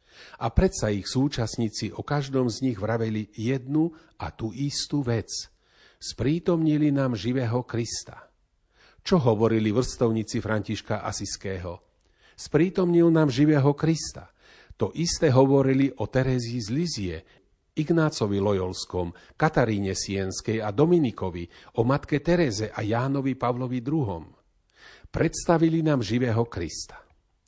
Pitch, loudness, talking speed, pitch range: 125 Hz, -25 LUFS, 110 wpm, 105-145 Hz